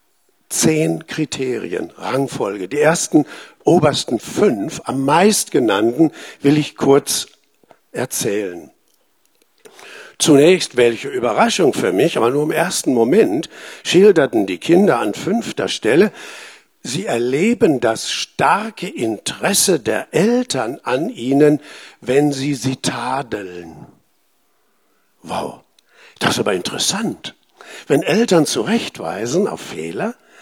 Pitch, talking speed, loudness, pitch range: 150 Hz, 105 wpm, -17 LUFS, 135-210 Hz